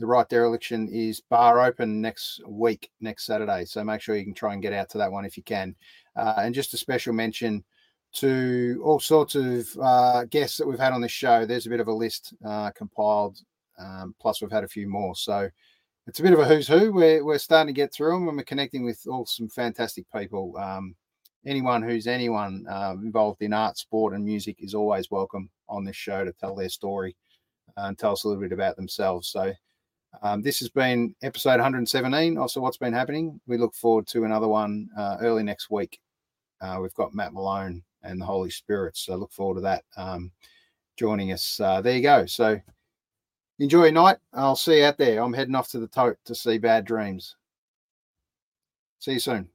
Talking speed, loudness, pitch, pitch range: 210 wpm, -25 LUFS, 115 Hz, 100-125 Hz